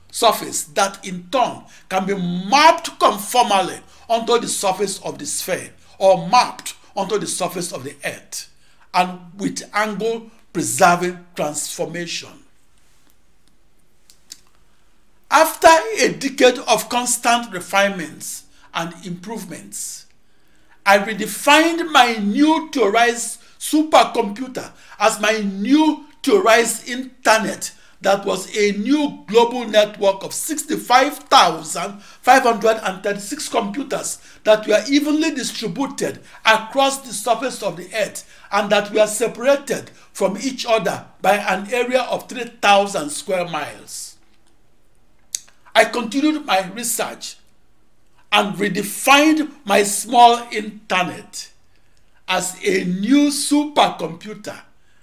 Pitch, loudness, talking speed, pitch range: 220 Hz, -18 LUFS, 100 wpm, 195-255 Hz